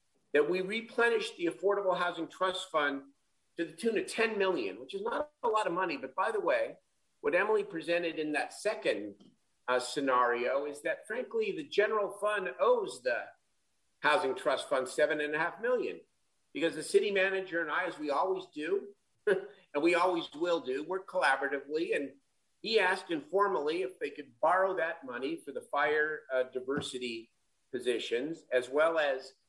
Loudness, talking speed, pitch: -32 LUFS, 175 wpm, 185 Hz